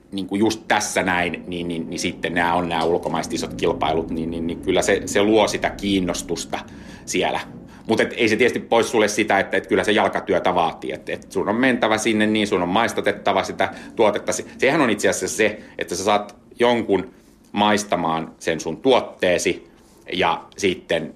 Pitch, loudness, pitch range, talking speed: 100 Hz, -21 LUFS, 85-105 Hz, 185 wpm